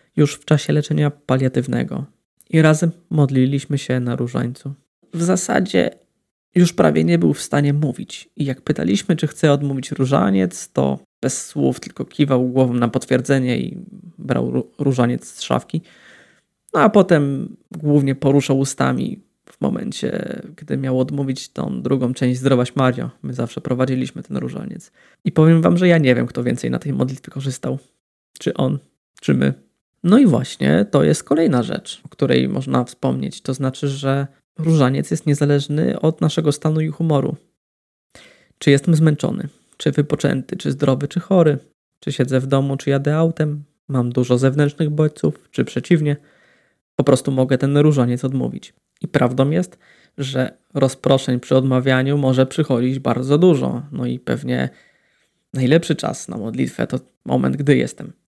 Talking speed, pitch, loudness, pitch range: 155 wpm, 140 Hz, -19 LUFS, 130-155 Hz